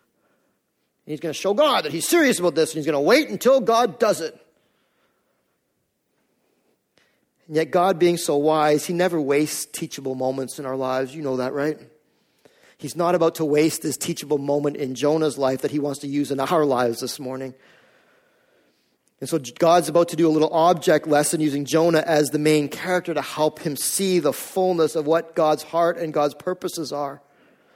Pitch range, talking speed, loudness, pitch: 145-170 Hz, 190 wpm, -21 LUFS, 155 Hz